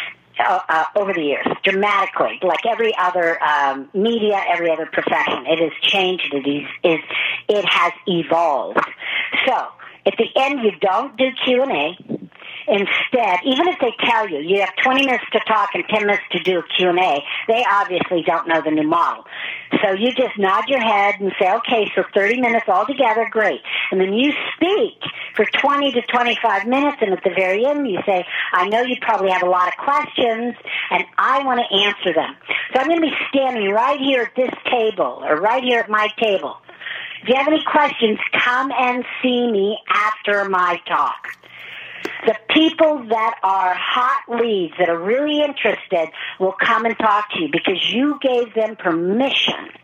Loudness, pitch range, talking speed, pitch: -18 LUFS, 185-250 Hz, 185 wpm, 215 Hz